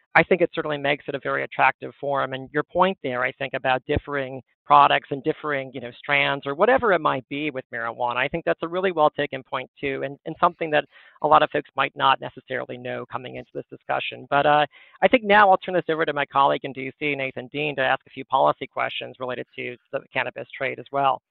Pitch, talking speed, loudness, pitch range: 140 Hz, 240 wpm, -23 LUFS, 130-150 Hz